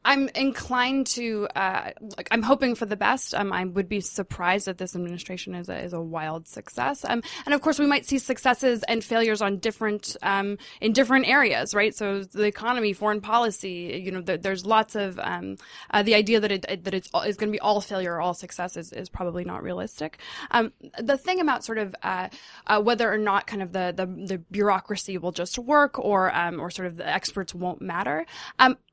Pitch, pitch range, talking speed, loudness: 205 Hz, 185-235 Hz, 215 wpm, -25 LUFS